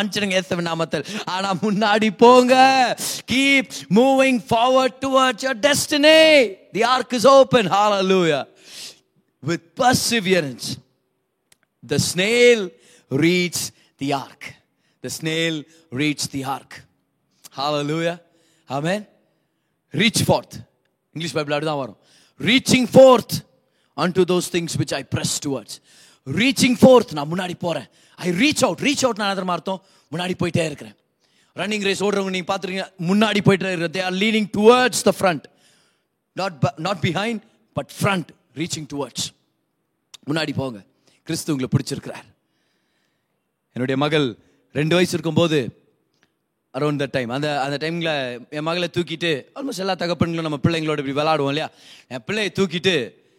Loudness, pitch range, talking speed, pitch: -19 LUFS, 150-215 Hz, 100 wpm, 175 Hz